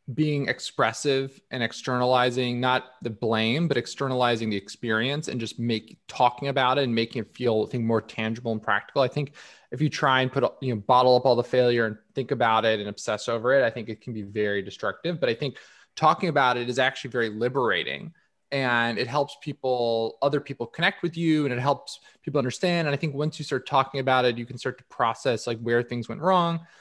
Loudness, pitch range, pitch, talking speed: -25 LUFS, 115-140 Hz, 125 Hz, 220 wpm